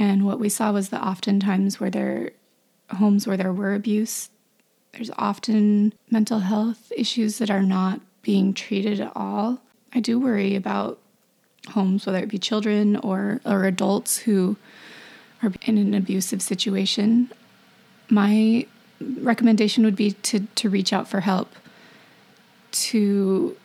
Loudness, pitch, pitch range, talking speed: -22 LUFS, 210 Hz, 195-225 Hz, 140 wpm